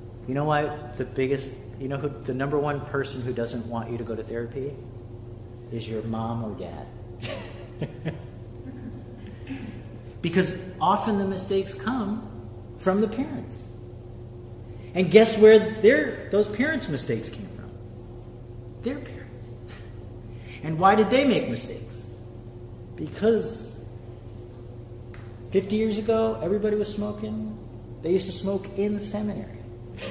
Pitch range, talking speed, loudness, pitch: 115-170 Hz, 130 wpm, -25 LUFS, 120 Hz